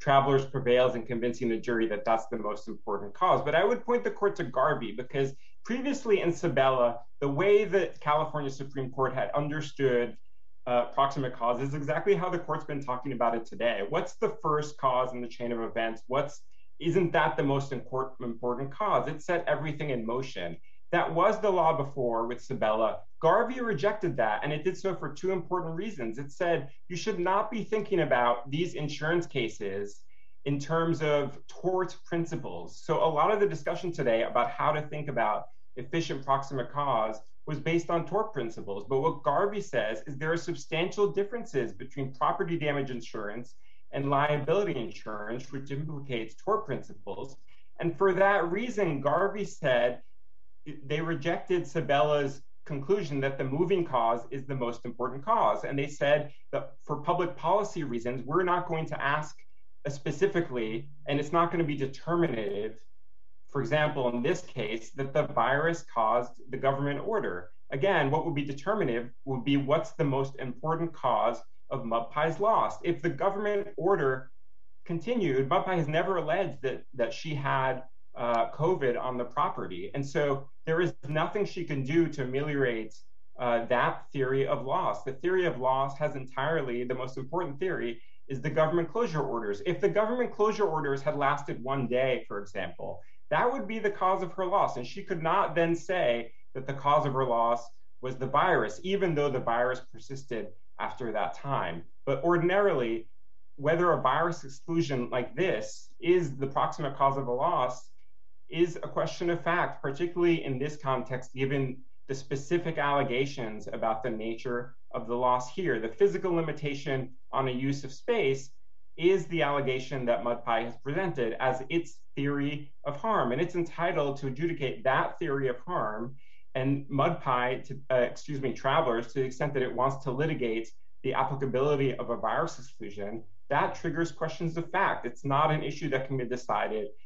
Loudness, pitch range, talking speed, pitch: -30 LUFS, 125-170 Hz, 175 wpm, 140 Hz